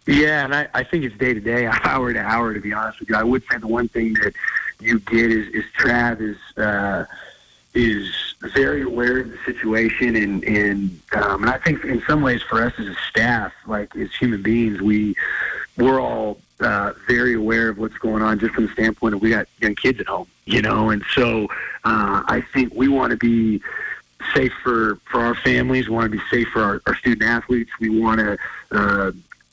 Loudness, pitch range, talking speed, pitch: -20 LUFS, 110-120 Hz, 215 wpm, 115 Hz